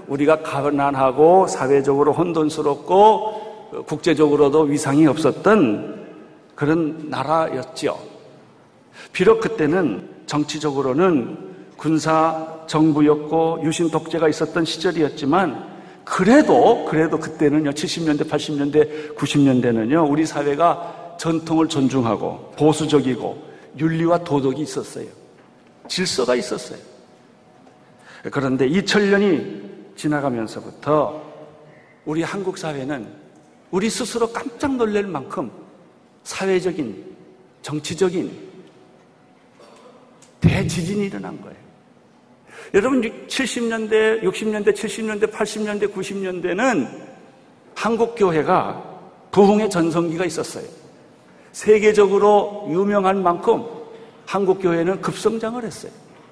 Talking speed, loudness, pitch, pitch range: 230 characters per minute, -19 LUFS, 165 Hz, 150-205 Hz